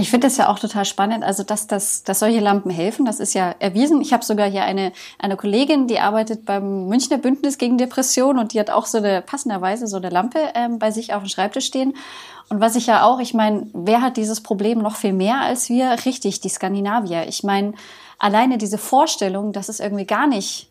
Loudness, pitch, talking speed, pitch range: -19 LUFS, 215 Hz, 225 wpm, 200-250 Hz